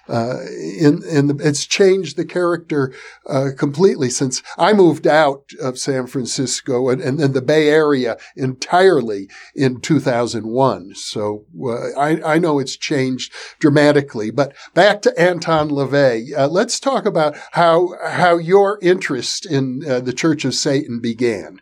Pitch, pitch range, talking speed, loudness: 145 Hz, 130-165 Hz, 150 wpm, -17 LUFS